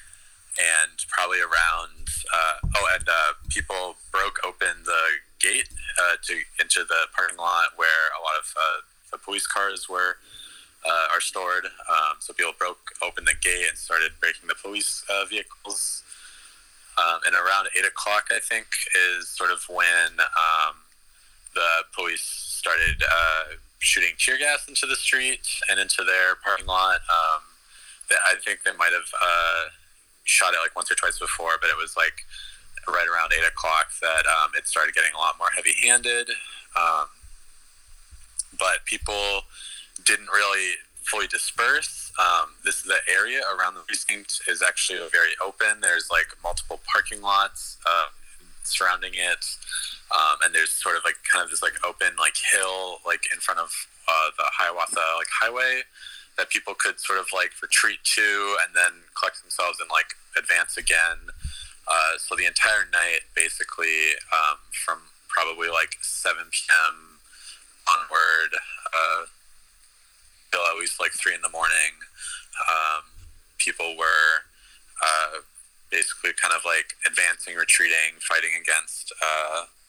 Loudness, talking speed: -22 LUFS, 150 wpm